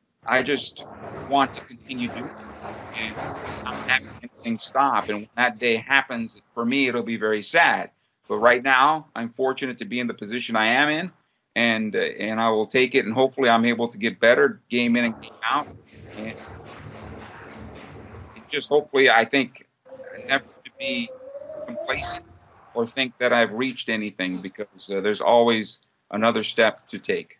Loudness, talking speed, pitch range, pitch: -22 LUFS, 170 wpm, 110-135 Hz, 120 Hz